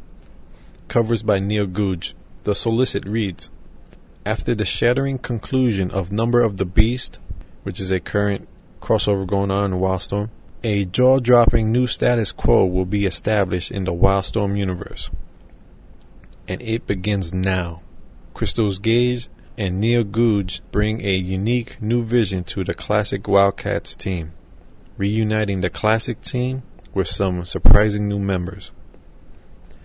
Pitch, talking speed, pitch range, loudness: 100 Hz, 135 wpm, 90-110 Hz, -21 LUFS